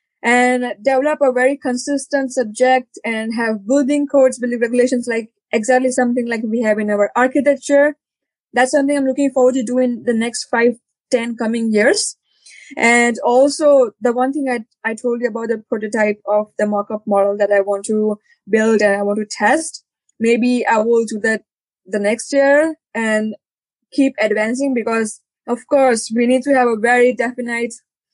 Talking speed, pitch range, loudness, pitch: 175 wpm, 220-260 Hz, -16 LUFS, 240 Hz